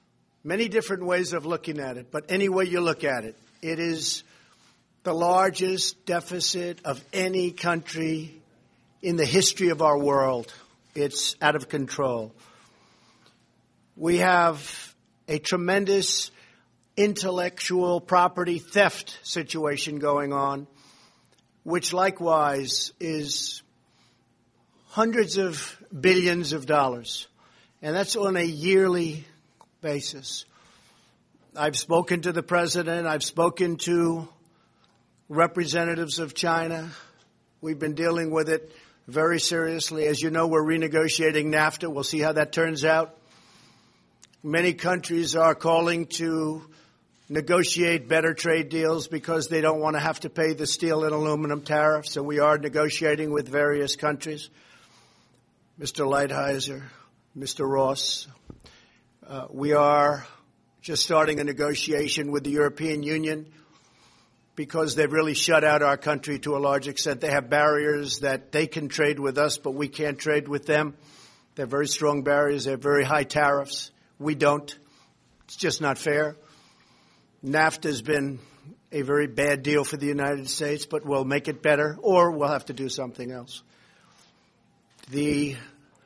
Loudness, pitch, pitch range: -25 LUFS, 155 Hz, 145-165 Hz